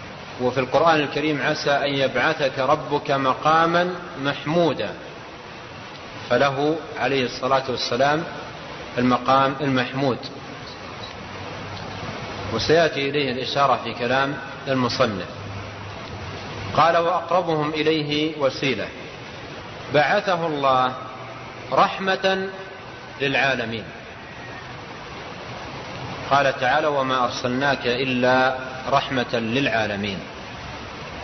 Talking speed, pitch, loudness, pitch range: 70 wpm, 135 Hz, -22 LUFS, 125-150 Hz